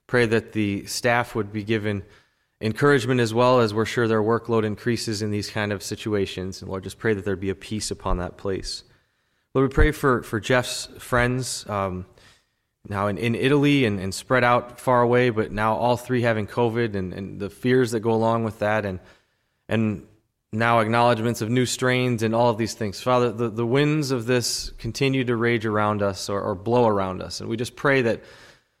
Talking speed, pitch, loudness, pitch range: 205 wpm, 115 Hz, -23 LUFS, 105-120 Hz